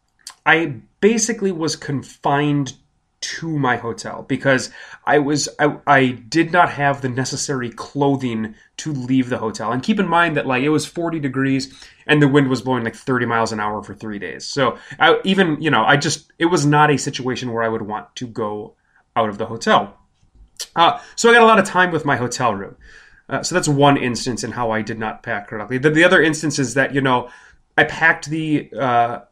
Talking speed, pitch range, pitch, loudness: 210 wpm, 120-155 Hz, 135 Hz, -18 LUFS